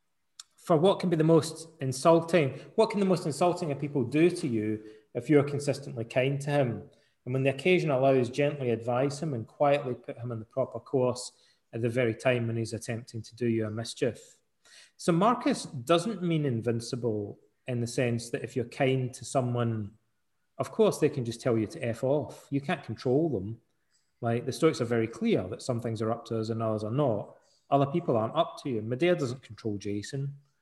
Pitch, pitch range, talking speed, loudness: 130 Hz, 115-150 Hz, 210 wpm, -29 LUFS